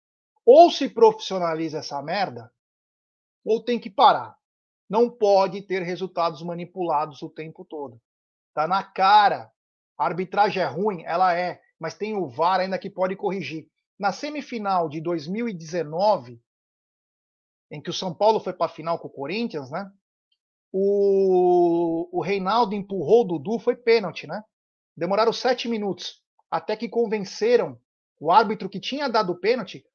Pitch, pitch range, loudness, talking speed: 190 Hz, 170-220 Hz, -23 LUFS, 145 wpm